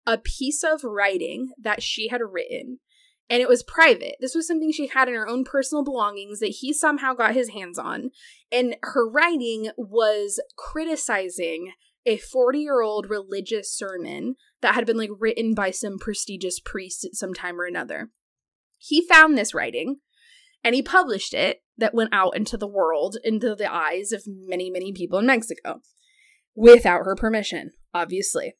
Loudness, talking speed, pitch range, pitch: -22 LUFS, 170 wpm, 200-280 Hz, 230 Hz